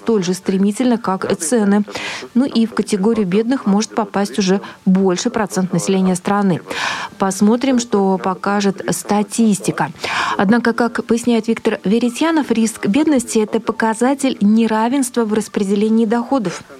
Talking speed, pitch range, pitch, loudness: 125 wpm, 200-235 Hz, 220 Hz, -16 LUFS